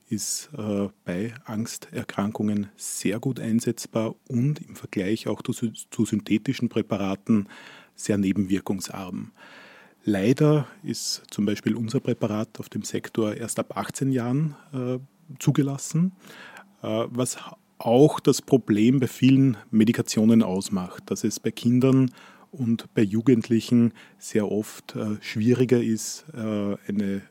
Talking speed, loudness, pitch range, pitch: 110 wpm, -25 LUFS, 105-130 Hz, 115 Hz